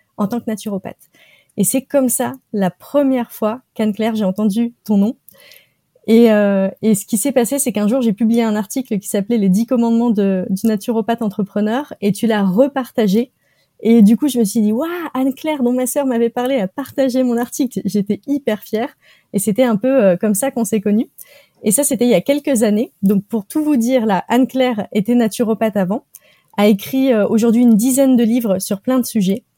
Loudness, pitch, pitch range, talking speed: -16 LUFS, 230 Hz, 210-255 Hz, 215 wpm